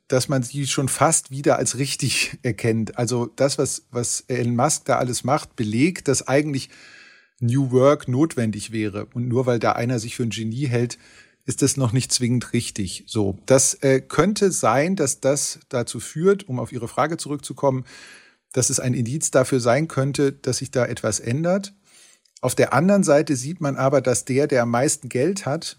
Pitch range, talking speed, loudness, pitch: 120-145 Hz, 190 wpm, -21 LUFS, 130 Hz